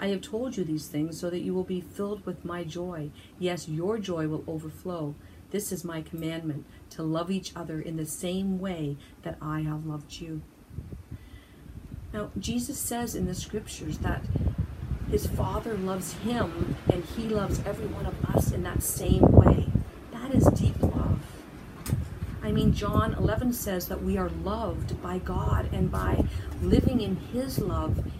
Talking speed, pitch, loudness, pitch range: 170 wpm, 165 Hz, -29 LUFS, 155-185 Hz